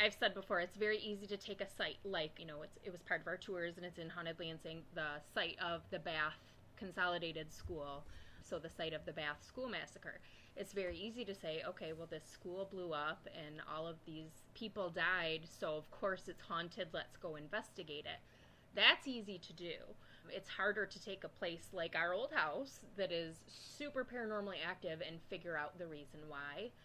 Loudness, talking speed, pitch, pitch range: -43 LUFS, 205 wpm, 175 Hz, 160-195 Hz